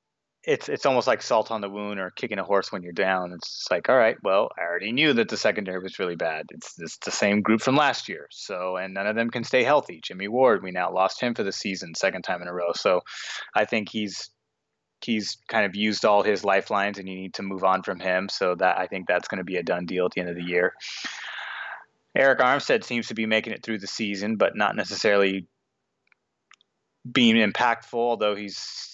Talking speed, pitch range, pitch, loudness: 235 wpm, 95-110 Hz, 100 Hz, -25 LUFS